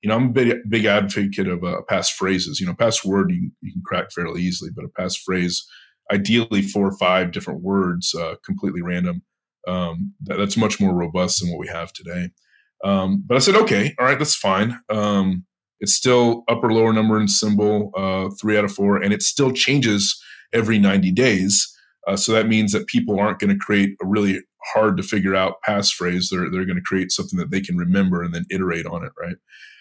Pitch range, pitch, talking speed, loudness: 95-115 Hz, 100 Hz, 215 wpm, -20 LUFS